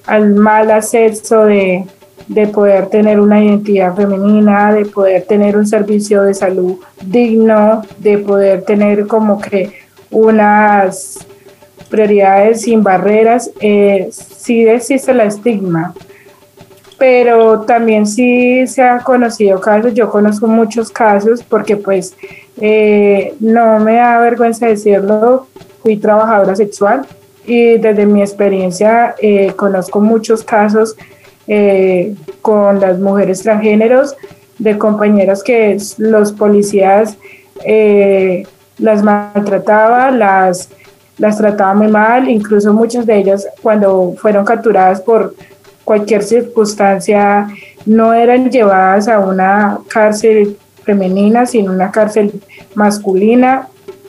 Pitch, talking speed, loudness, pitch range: 210 Hz, 110 wpm, -10 LUFS, 200-225 Hz